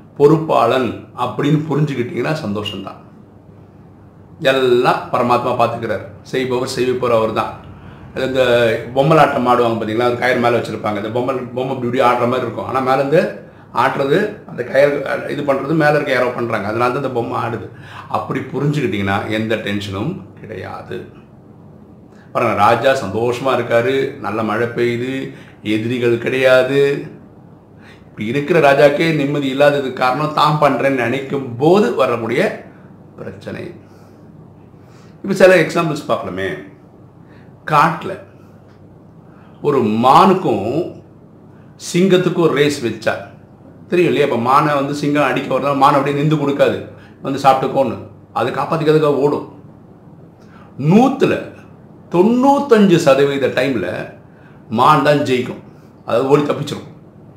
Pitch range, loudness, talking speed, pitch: 120-145 Hz, -16 LUFS, 100 wpm, 130 Hz